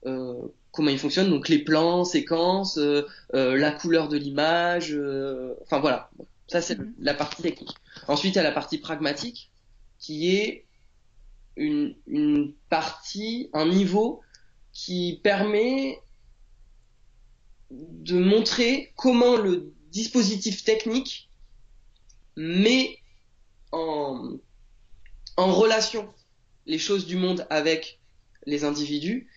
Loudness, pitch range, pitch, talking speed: -25 LUFS, 145-210 Hz, 165 Hz, 110 wpm